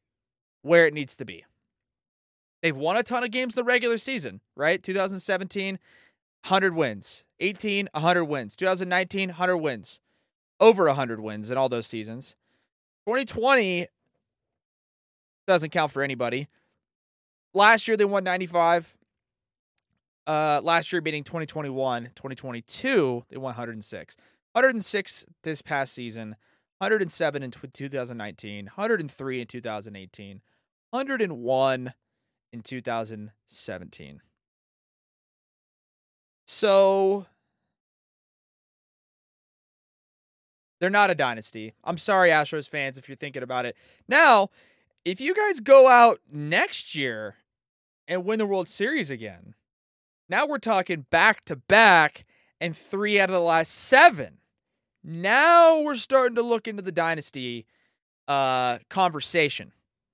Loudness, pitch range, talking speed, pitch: -23 LUFS, 125-195 Hz, 115 wpm, 160 Hz